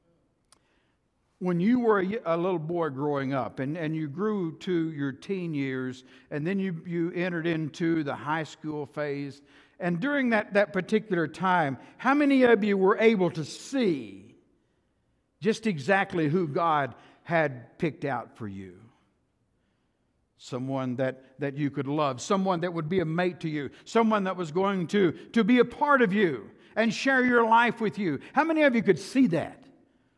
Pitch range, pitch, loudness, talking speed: 145-210 Hz, 175 Hz, -27 LUFS, 175 wpm